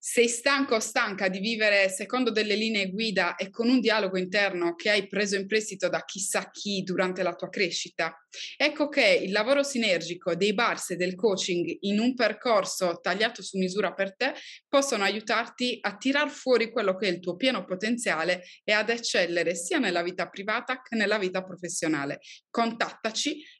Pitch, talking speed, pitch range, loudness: 205 Hz, 175 wpm, 185-235 Hz, -26 LUFS